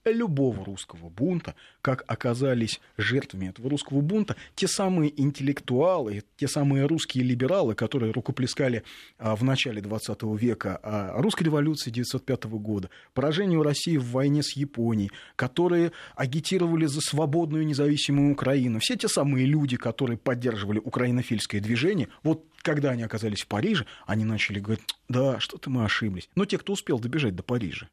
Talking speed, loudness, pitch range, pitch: 145 wpm, -27 LUFS, 110-150 Hz, 130 Hz